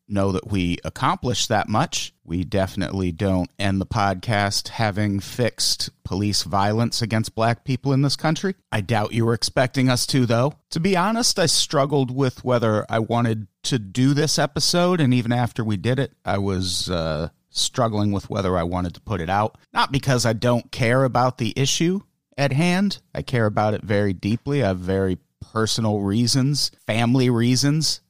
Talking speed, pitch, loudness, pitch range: 180 wpm, 115 Hz, -22 LUFS, 100-135 Hz